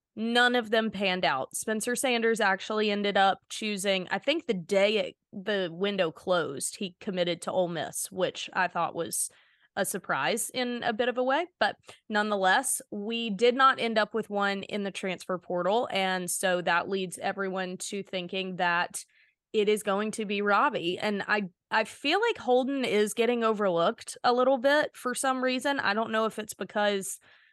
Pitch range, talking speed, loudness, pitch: 190-240 Hz, 185 wpm, -28 LUFS, 210 Hz